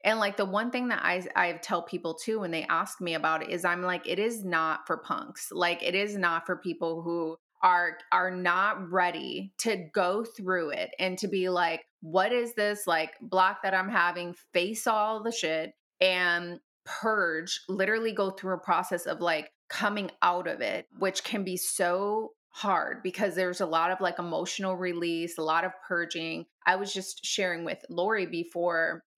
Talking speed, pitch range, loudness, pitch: 190 wpm, 170-200 Hz, -29 LUFS, 180 Hz